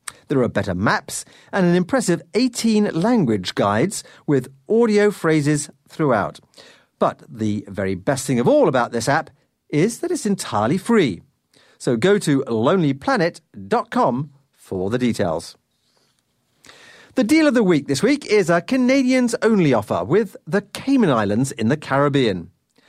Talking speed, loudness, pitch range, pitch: 145 wpm, -19 LUFS, 135-220 Hz, 170 Hz